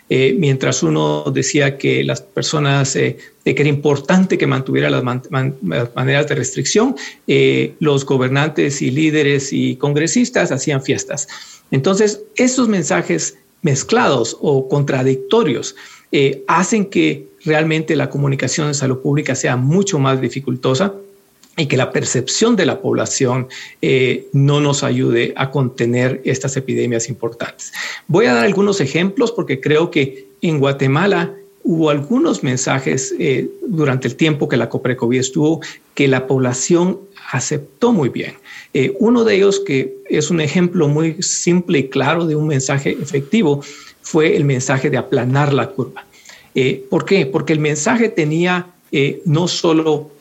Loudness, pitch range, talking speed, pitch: -16 LUFS, 130-175 Hz, 150 wpm, 145 Hz